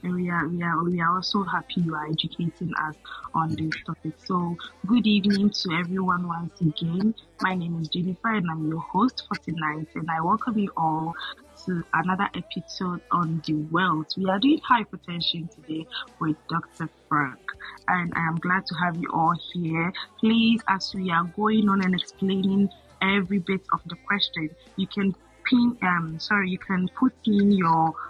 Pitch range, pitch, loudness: 165-200 Hz, 180 Hz, -25 LUFS